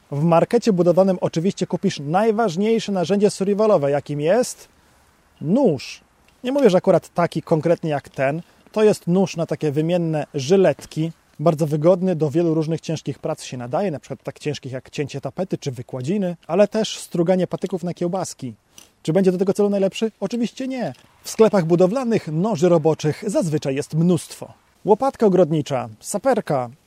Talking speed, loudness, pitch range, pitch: 155 wpm, -20 LUFS, 155-195 Hz, 175 Hz